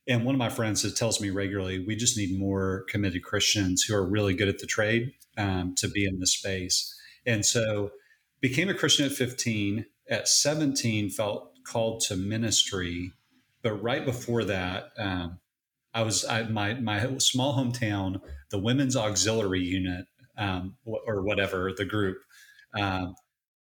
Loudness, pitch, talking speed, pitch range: -27 LUFS, 105 Hz, 160 wpm, 95-120 Hz